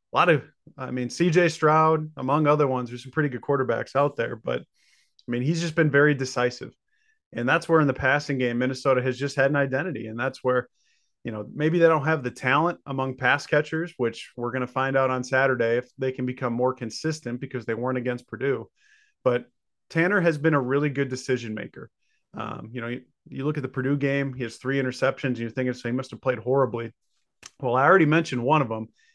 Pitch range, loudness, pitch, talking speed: 125-150 Hz, -25 LUFS, 130 Hz, 225 wpm